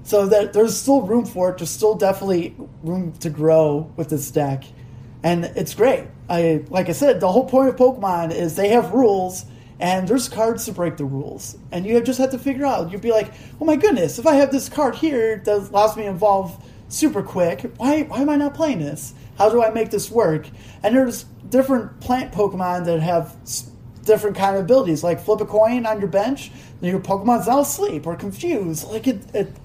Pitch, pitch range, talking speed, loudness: 195 Hz, 165-235 Hz, 215 wpm, -19 LUFS